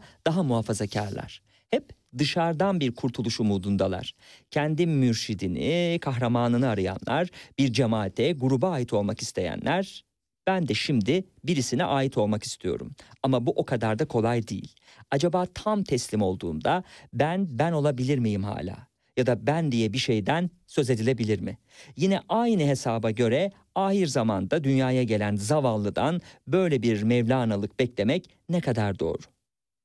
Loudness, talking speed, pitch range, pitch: -26 LUFS, 130 wpm, 110-150 Hz, 125 Hz